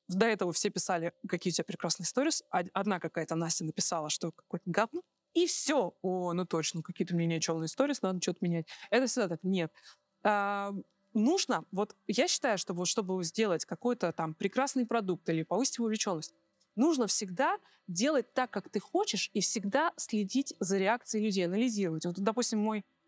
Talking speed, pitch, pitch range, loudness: 170 wpm, 200 Hz, 175-230 Hz, -32 LUFS